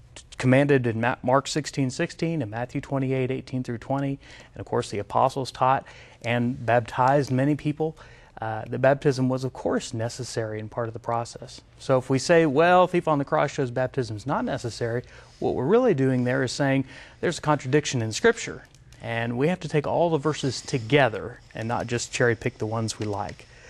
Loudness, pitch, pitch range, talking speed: -25 LUFS, 130 Hz, 120-145 Hz, 200 wpm